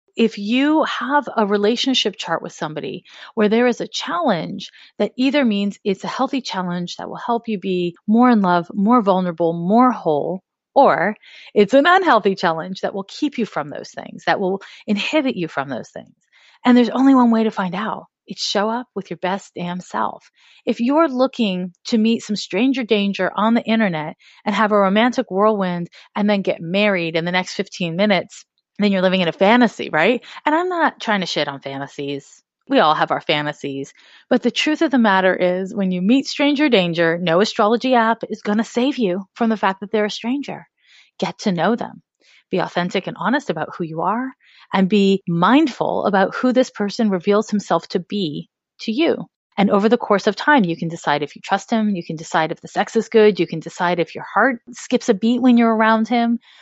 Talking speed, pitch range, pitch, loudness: 210 wpm, 185-240 Hz, 210 Hz, -18 LUFS